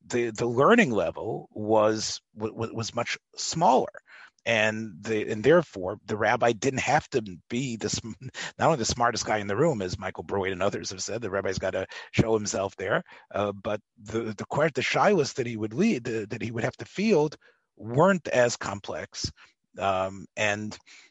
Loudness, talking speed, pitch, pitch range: -27 LUFS, 180 wpm, 110 Hz, 105-120 Hz